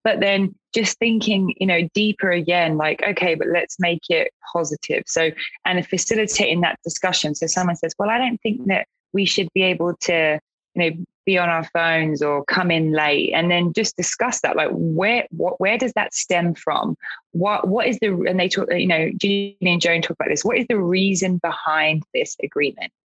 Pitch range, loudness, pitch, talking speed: 170-205 Hz, -20 LUFS, 180 Hz, 200 wpm